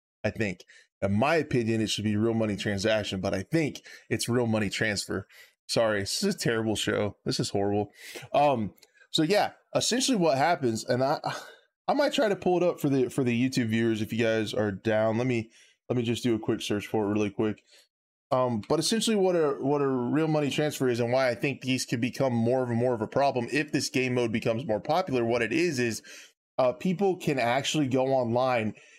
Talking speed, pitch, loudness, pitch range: 225 wpm, 120 Hz, -27 LUFS, 110-140 Hz